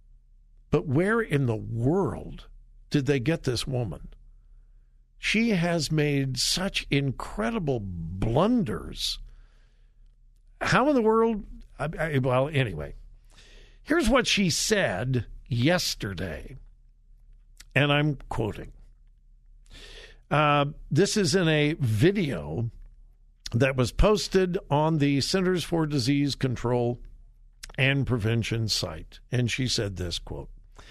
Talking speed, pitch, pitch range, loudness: 105 wpm, 135 Hz, 110-160 Hz, -26 LUFS